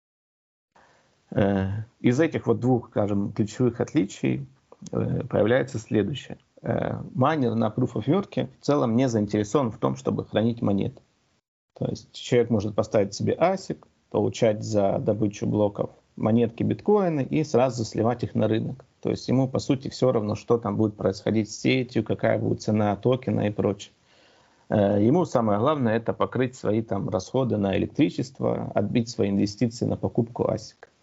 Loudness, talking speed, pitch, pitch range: -25 LUFS, 145 wpm, 110 Hz, 100-125 Hz